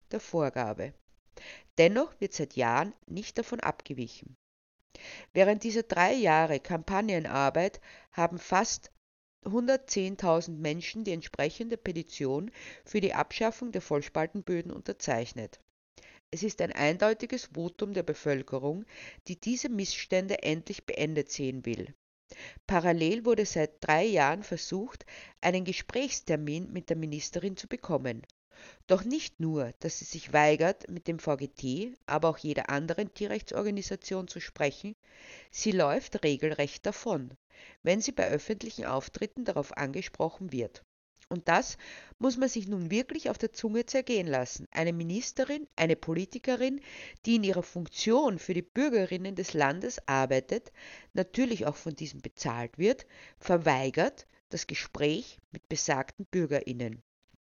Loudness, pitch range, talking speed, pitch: -31 LUFS, 150-215 Hz, 125 wpm, 175 Hz